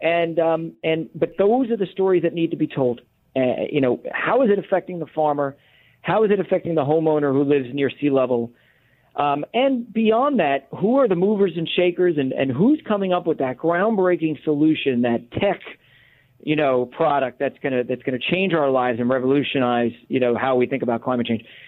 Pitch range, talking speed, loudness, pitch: 130-180 Hz, 210 wpm, -21 LUFS, 150 Hz